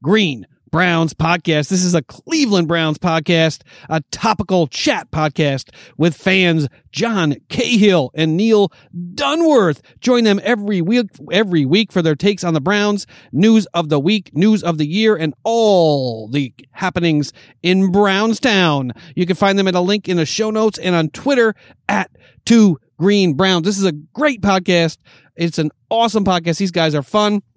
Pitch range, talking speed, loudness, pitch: 160-210 Hz, 170 wpm, -16 LUFS, 180 Hz